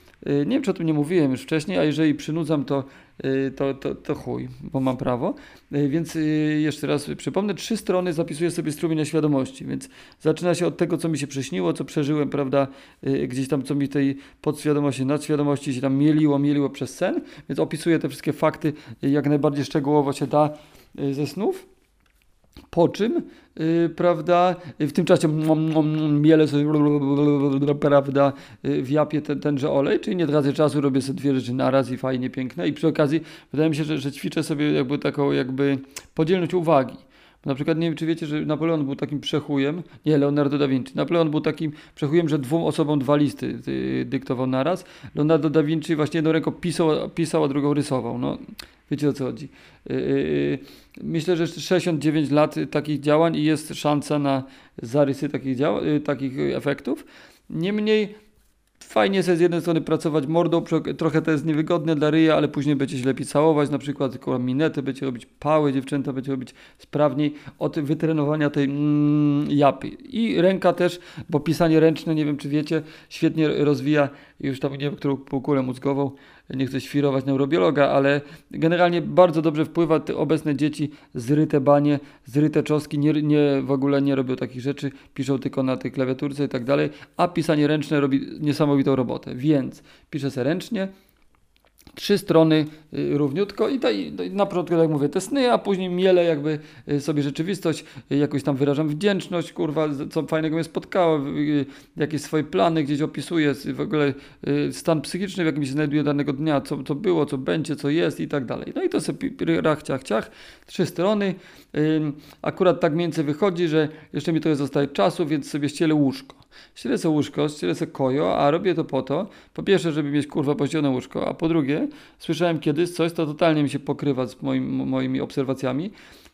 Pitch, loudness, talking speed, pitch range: 150 Hz, -23 LUFS, 185 wpm, 140-160 Hz